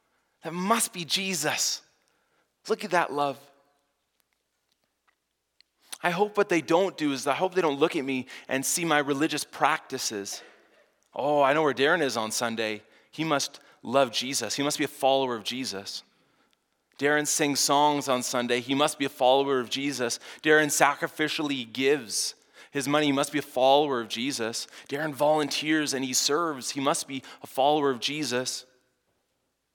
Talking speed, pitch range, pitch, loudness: 165 wpm, 130-155 Hz, 140 Hz, -26 LUFS